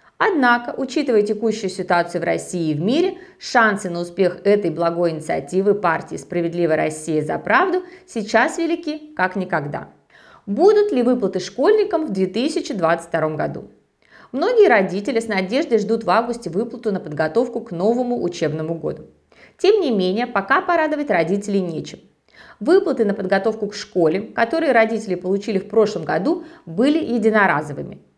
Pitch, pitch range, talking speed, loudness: 215 Hz, 180-280 Hz, 140 wpm, -19 LUFS